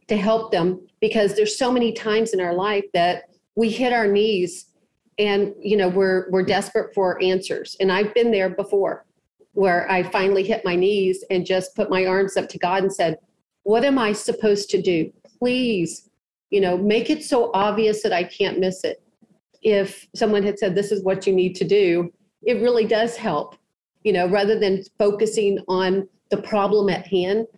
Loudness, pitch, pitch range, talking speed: -21 LUFS, 200 Hz, 185-220 Hz, 190 wpm